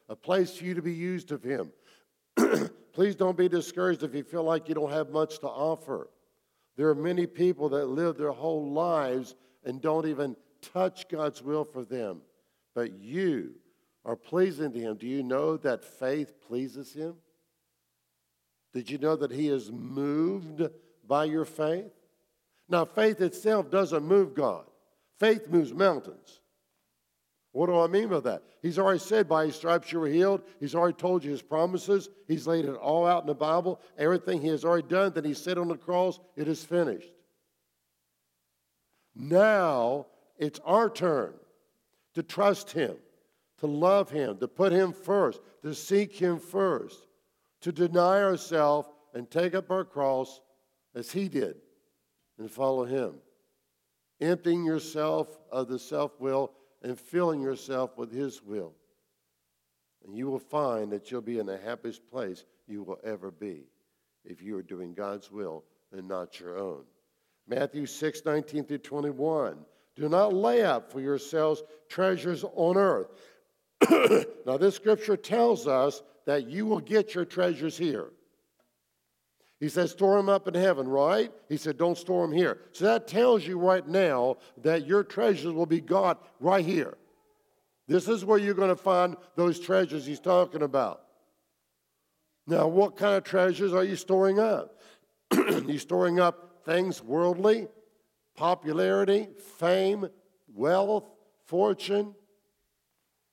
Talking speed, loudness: 155 wpm, -28 LUFS